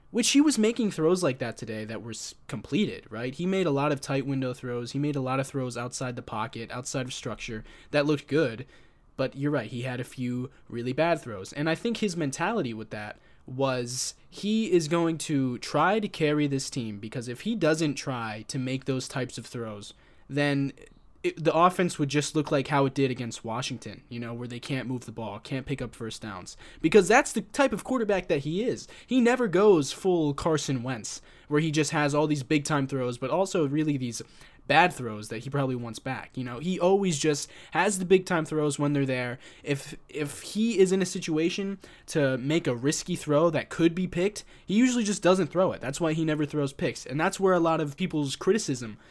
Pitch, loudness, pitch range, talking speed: 145 Hz, -27 LUFS, 125-170 Hz, 225 wpm